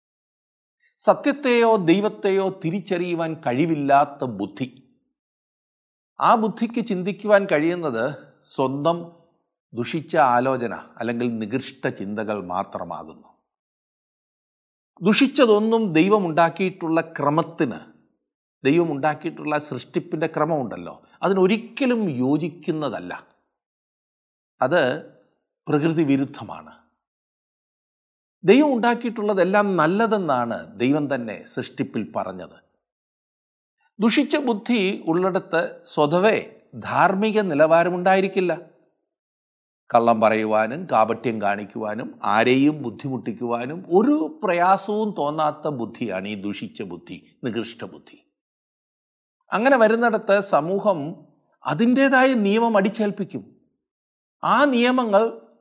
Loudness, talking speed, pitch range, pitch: -21 LUFS, 65 wpm, 140-210 Hz, 170 Hz